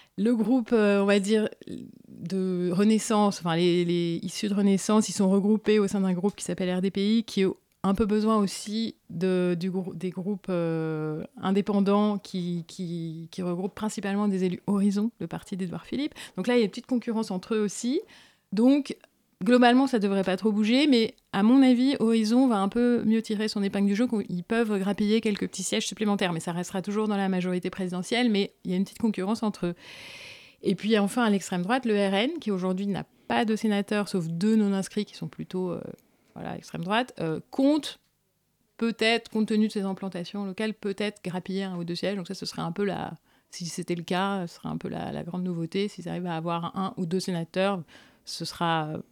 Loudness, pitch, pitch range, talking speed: -27 LUFS, 200 Hz, 185-220 Hz, 215 wpm